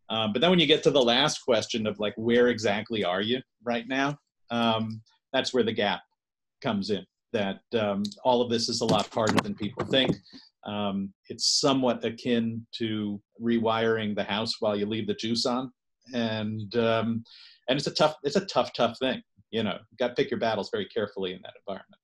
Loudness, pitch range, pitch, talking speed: -27 LUFS, 110-125 Hz, 115 Hz, 205 wpm